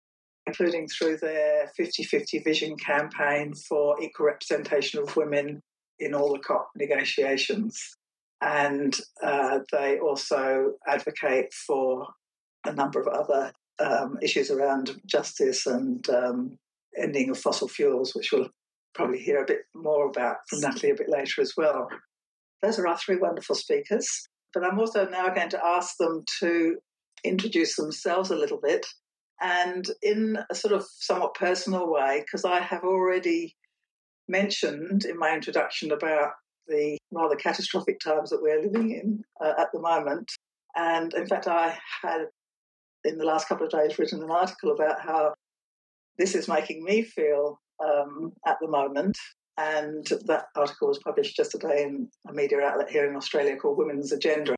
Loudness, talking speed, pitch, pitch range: -27 LUFS, 155 wpm, 170 Hz, 150-230 Hz